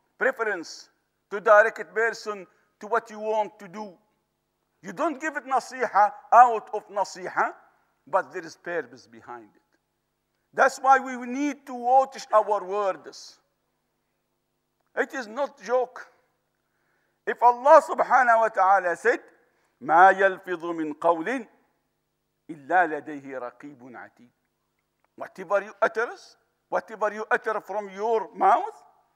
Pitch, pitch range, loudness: 210 Hz, 185-245 Hz, -24 LUFS